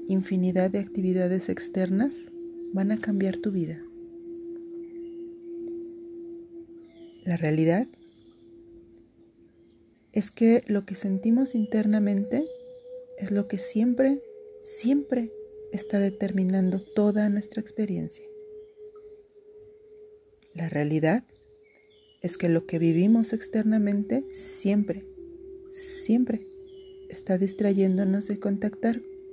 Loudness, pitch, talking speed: -26 LUFS, 230 Hz, 85 wpm